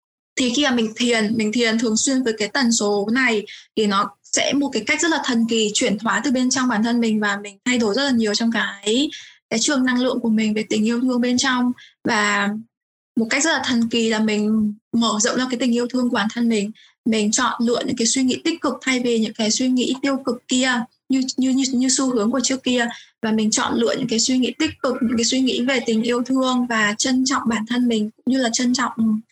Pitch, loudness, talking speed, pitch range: 240 Hz, -20 LUFS, 265 wpm, 220-260 Hz